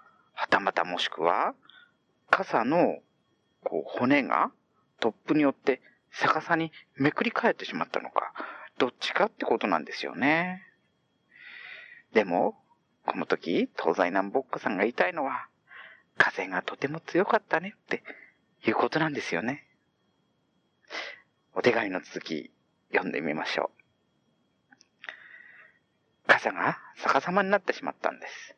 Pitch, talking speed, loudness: 205 Hz, 250 characters per minute, -28 LUFS